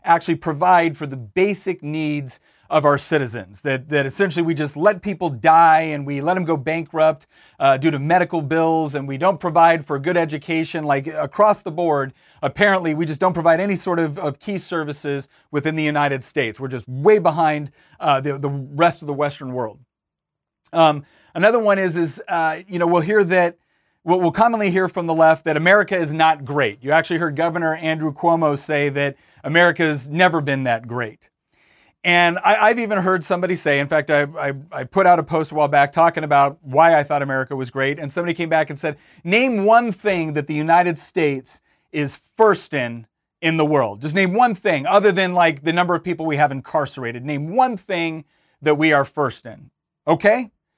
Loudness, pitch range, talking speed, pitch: -19 LUFS, 145-175 Hz, 200 wpm, 160 Hz